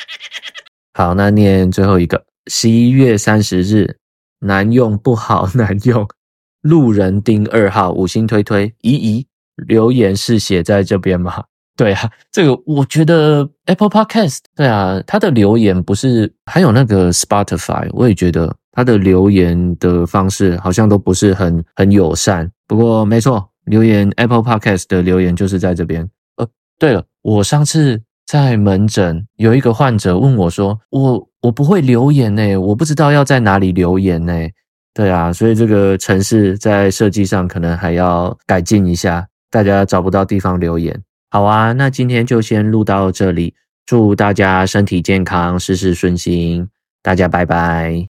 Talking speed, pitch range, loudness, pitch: 265 characters per minute, 90-115 Hz, -13 LUFS, 100 Hz